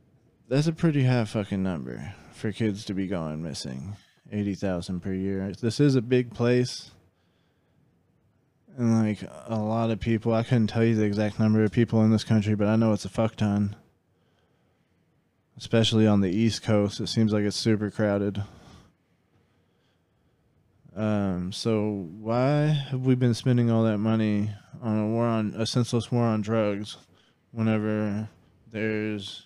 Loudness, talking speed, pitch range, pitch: -26 LUFS, 160 wpm, 100-115 Hz, 110 Hz